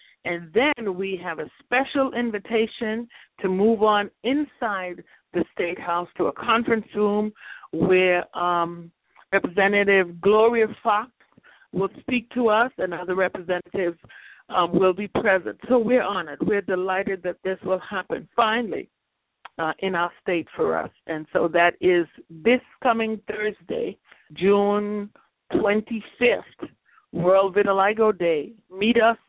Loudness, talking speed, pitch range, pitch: -23 LUFS, 130 wpm, 180-225 Hz, 200 Hz